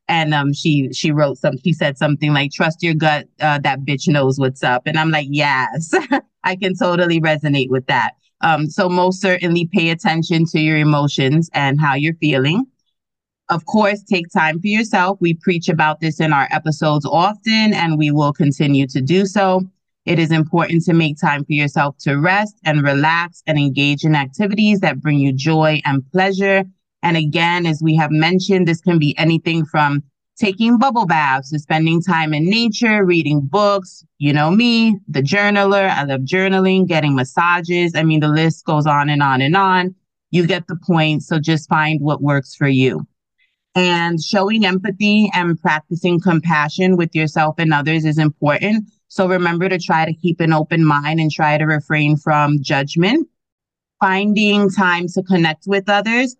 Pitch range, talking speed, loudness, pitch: 150-185 Hz, 180 wpm, -16 LUFS, 165 Hz